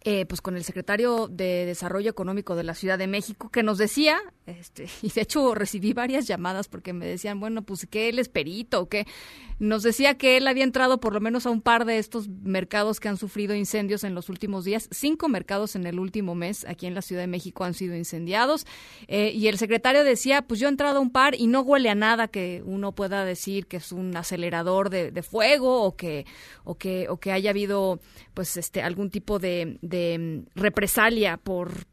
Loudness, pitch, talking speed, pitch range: -25 LUFS, 205 Hz, 215 wpm, 180-225 Hz